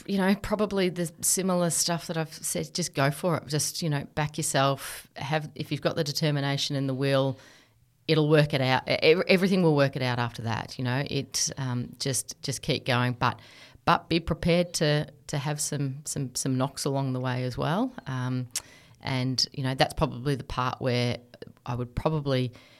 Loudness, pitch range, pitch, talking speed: -27 LUFS, 130-160 Hz, 140 Hz, 195 wpm